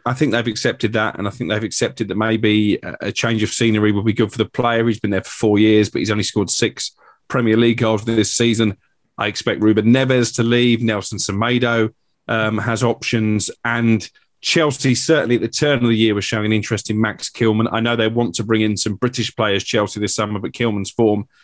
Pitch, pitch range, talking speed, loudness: 110 Hz, 105-120 Hz, 225 wpm, -18 LUFS